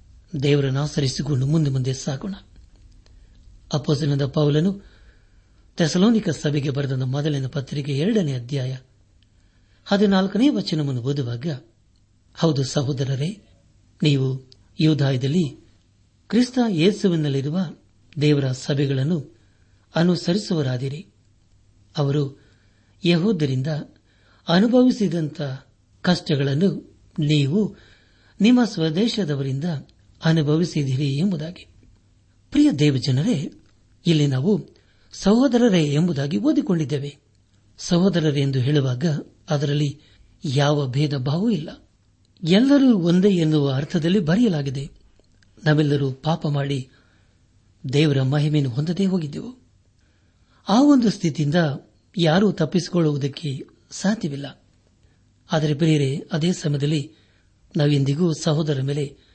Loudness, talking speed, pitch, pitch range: -21 LUFS, 75 wpm, 145 Hz, 110-170 Hz